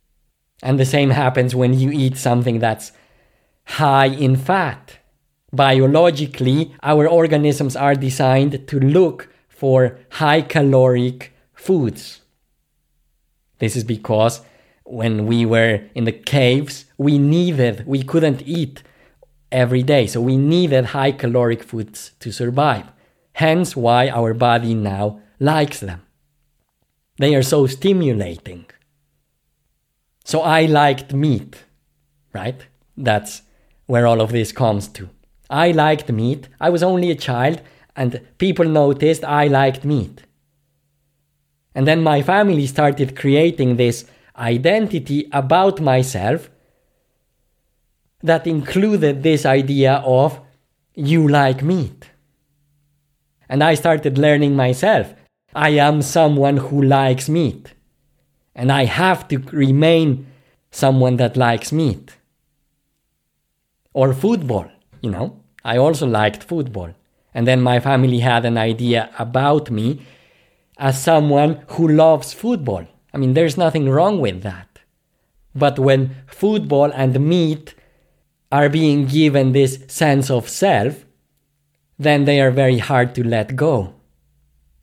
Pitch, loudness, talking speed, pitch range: 135 Hz, -16 LUFS, 120 wpm, 120-150 Hz